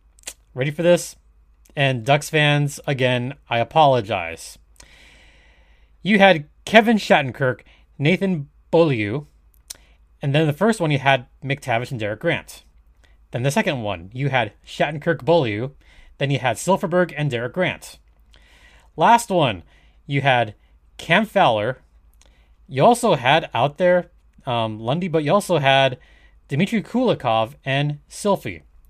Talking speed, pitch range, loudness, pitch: 130 wpm, 105-165 Hz, -20 LUFS, 135 Hz